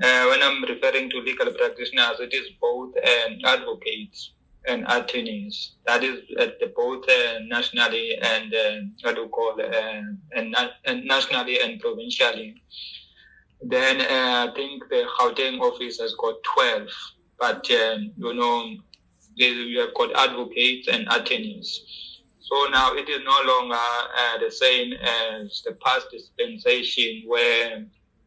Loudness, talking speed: -22 LUFS, 135 wpm